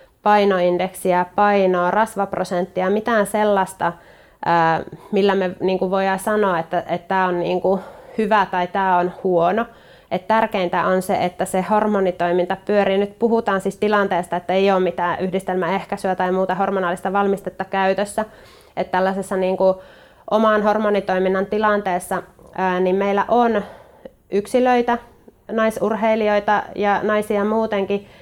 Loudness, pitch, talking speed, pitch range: -19 LUFS, 190 Hz, 110 wpm, 185-205 Hz